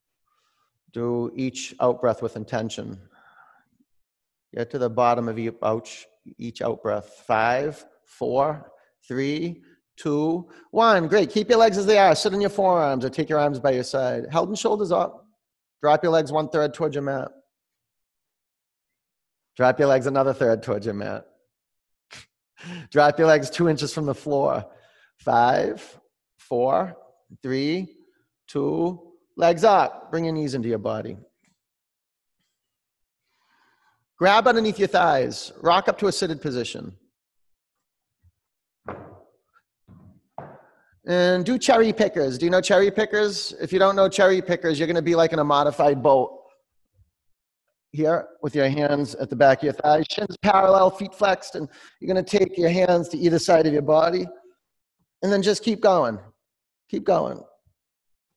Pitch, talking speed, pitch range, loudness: 160 Hz, 150 wpm, 135-190 Hz, -22 LUFS